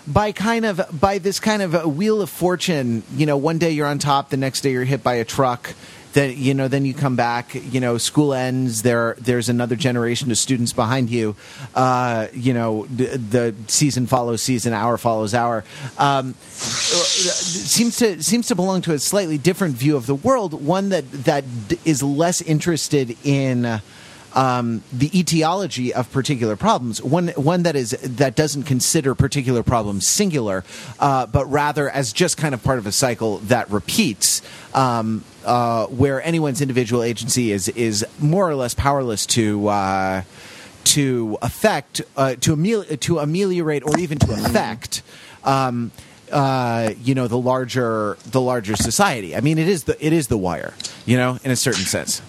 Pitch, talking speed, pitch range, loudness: 135 Hz, 180 wpm, 120-155 Hz, -19 LUFS